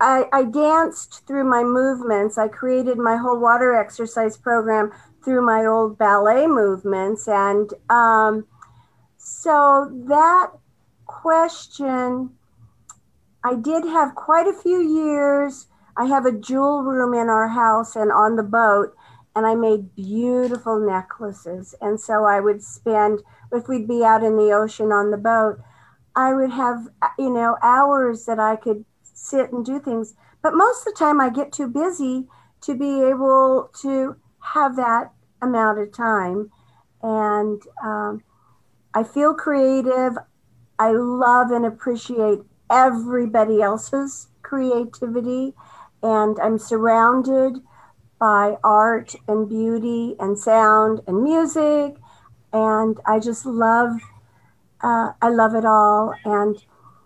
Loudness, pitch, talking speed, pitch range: -19 LUFS, 235 Hz, 130 wpm, 215-265 Hz